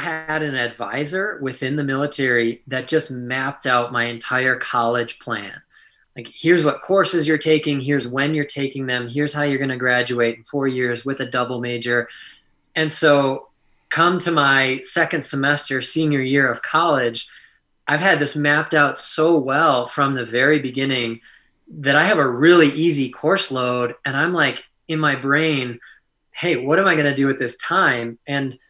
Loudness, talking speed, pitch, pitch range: -19 LUFS, 180 wpm, 140 Hz, 125-150 Hz